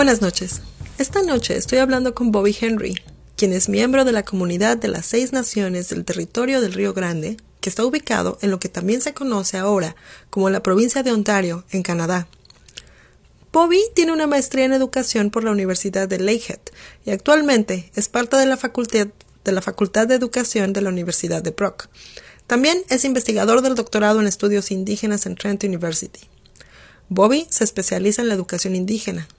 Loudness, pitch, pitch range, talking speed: -17 LUFS, 210 Hz, 190-245 Hz, 180 wpm